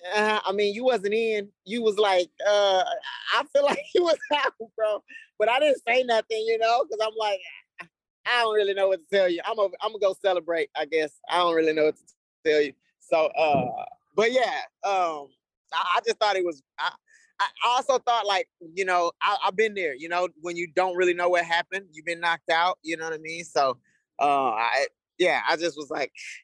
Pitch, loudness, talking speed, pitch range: 205 Hz, -25 LUFS, 225 wpm, 175-240 Hz